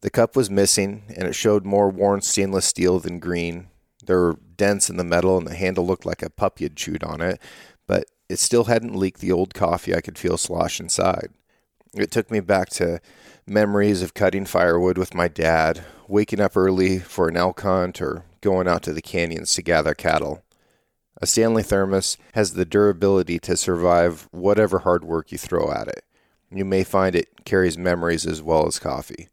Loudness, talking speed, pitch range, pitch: -21 LUFS, 195 wpm, 85-100 Hz, 95 Hz